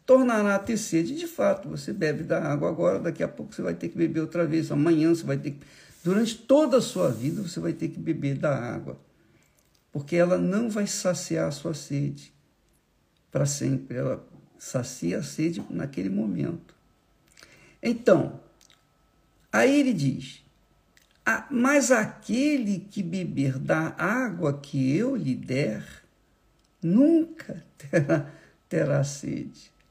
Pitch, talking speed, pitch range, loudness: 170 Hz, 145 wpm, 145-215 Hz, -26 LUFS